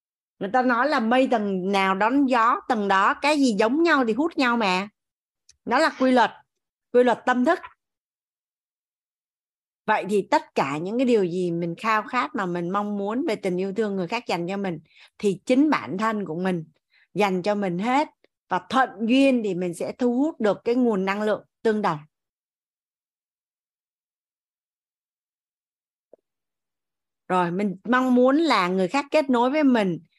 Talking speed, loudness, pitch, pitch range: 175 wpm, -23 LUFS, 220 Hz, 190-255 Hz